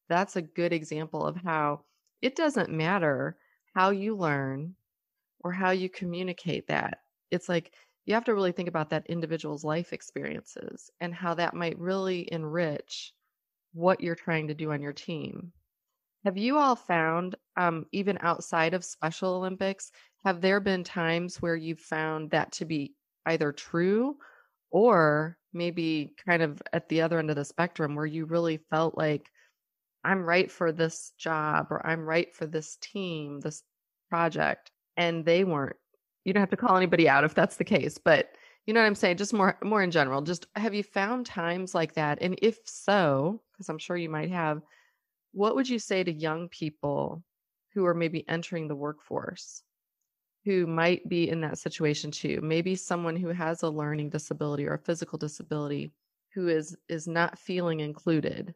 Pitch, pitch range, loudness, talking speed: 170 Hz, 155-185 Hz, -29 LUFS, 175 wpm